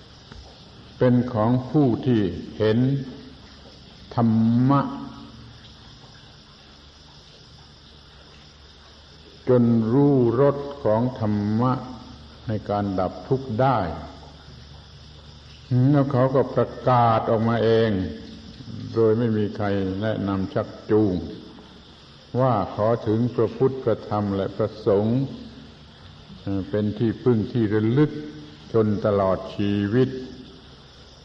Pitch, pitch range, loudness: 105 Hz, 75-120 Hz, -22 LUFS